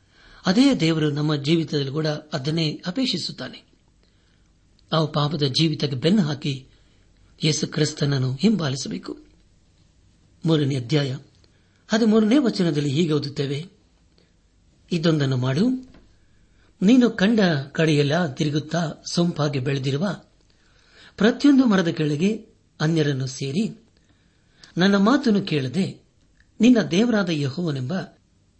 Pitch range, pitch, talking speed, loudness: 115-175 Hz, 150 Hz, 85 wpm, -22 LUFS